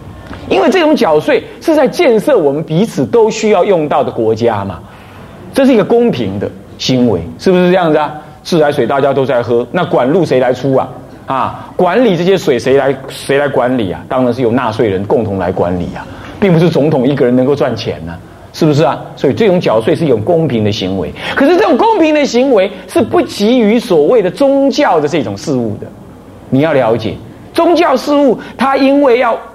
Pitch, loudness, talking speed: 150 Hz, -11 LUFS, 300 characters per minute